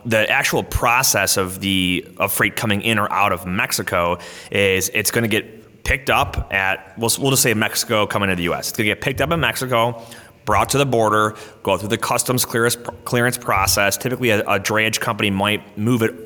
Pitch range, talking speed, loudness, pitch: 100-120 Hz, 205 wpm, -18 LUFS, 110 Hz